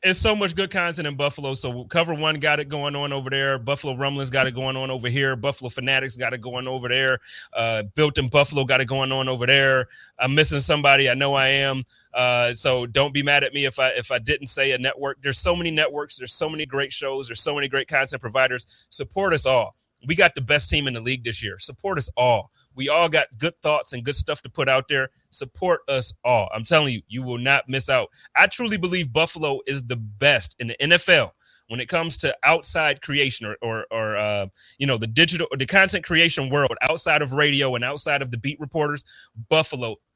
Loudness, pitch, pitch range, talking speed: -21 LUFS, 135 Hz, 130-150 Hz, 235 wpm